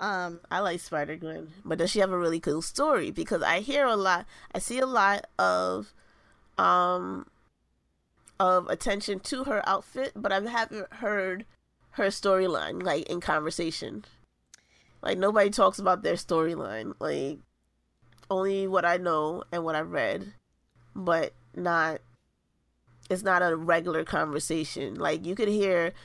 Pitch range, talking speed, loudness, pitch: 150-195 Hz, 145 wpm, -28 LUFS, 175 Hz